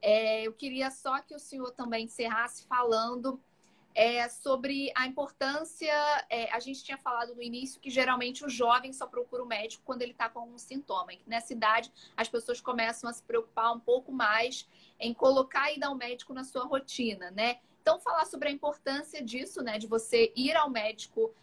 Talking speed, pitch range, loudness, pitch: 190 wpm, 230-275 Hz, -31 LUFS, 250 Hz